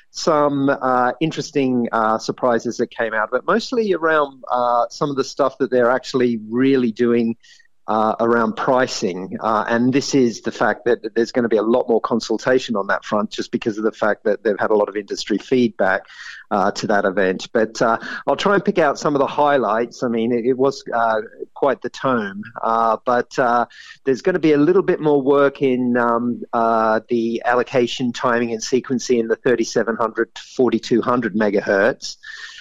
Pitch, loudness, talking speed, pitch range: 125 Hz, -19 LUFS, 195 wpm, 115-140 Hz